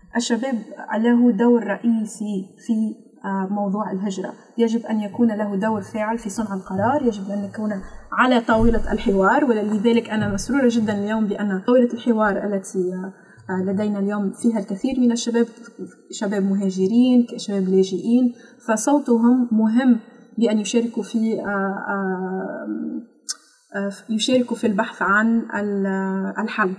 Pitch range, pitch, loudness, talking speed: 200-235 Hz, 215 Hz, -21 LUFS, 115 wpm